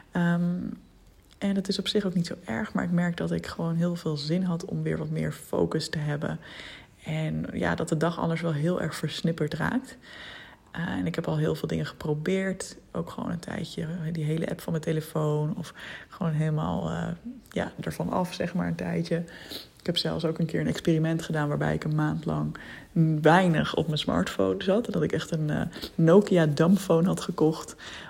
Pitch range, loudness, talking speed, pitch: 155-180 Hz, -28 LUFS, 205 wpm, 165 Hz